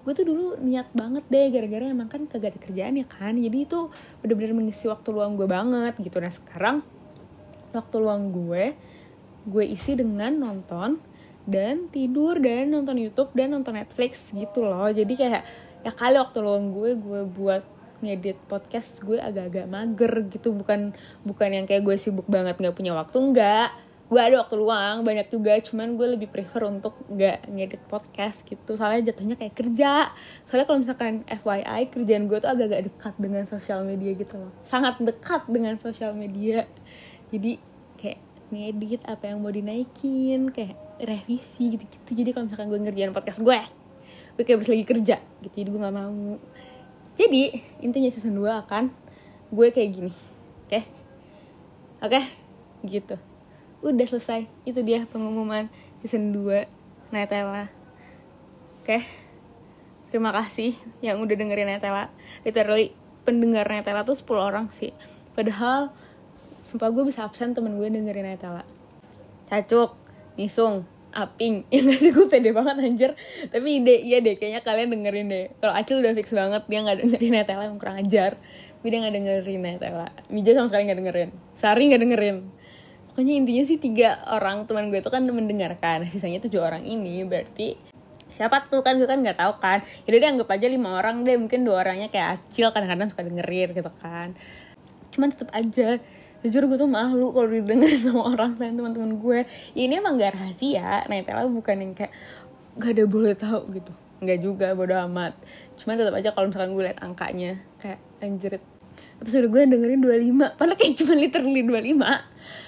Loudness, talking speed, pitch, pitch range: -24 LUFS, 170 wpm, 220 Hz, 200-245 Hz